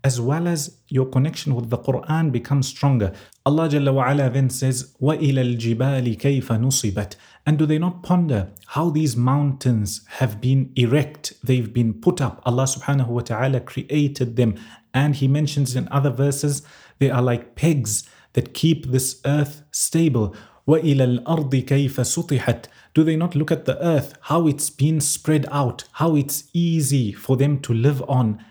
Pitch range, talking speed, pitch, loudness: 125-150 Hz, 150 wpm, 135 Hz, -21 LUFS